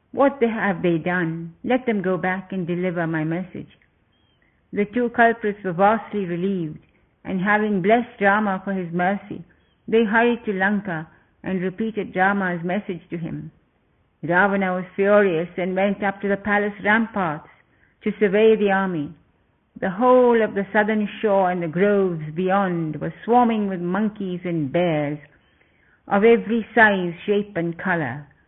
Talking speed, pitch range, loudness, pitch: 150 wpm, 175-210 Hz, -21 LUFS, 195 Hz